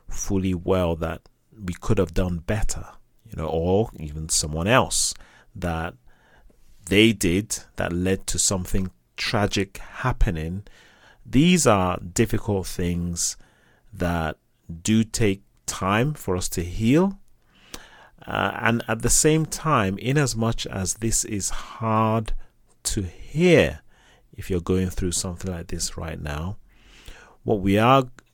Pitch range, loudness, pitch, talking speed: 90-115 Hz, -23 LUFS, 100 Hz, 130 wpm